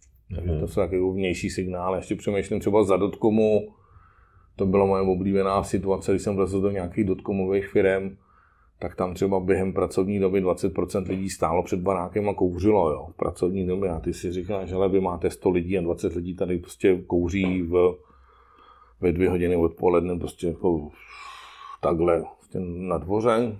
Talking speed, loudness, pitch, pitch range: 165 wpm, -25 LUFS, 95 Hz, 90-100 Hz